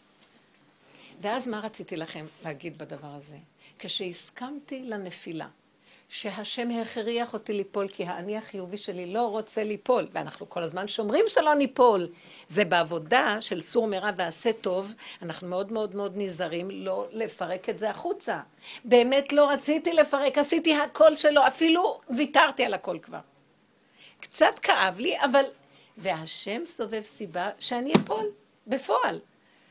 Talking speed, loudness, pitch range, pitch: 130 wpm, -26 LUFS, 185-250 Hz, 215 Hz